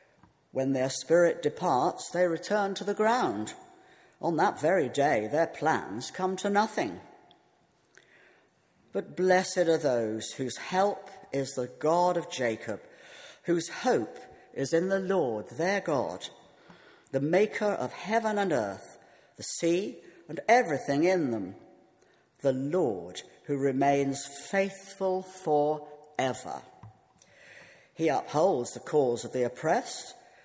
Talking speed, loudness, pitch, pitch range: 125 wpm, -29 LUFS, 175 Hz, 140-195 Hz